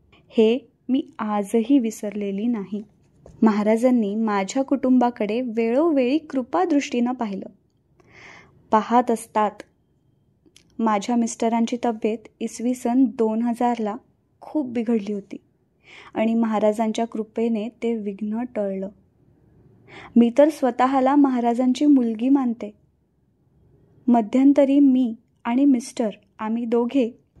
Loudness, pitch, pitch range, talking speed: -22 LUFS, 235 Hz, 220-260 Hz, 90 wpm